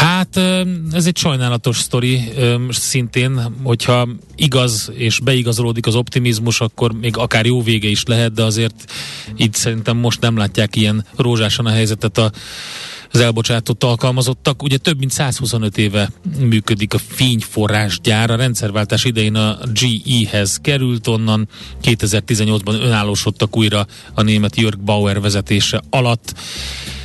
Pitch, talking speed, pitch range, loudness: 115 Hz, 125 wpm, 110-125 Hz, -16 LUFS